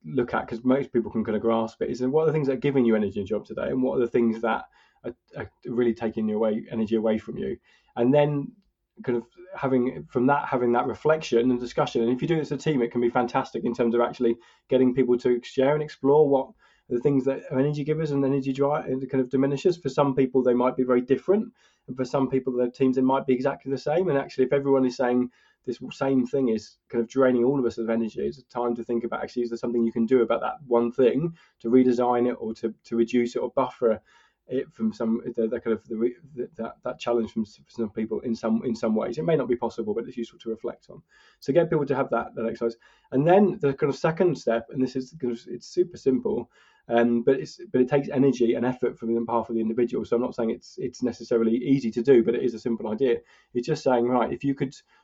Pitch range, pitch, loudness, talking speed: 115-135 Hz, 125 Hz, -25 LUFS, 265 wpm